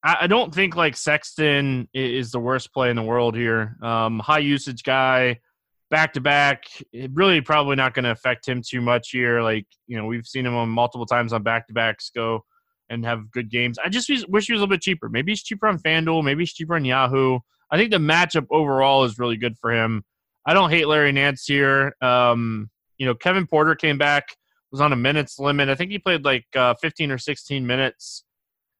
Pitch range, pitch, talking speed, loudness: 120-155 Hz, 135 Hz, 215 wpm, -21 LUFS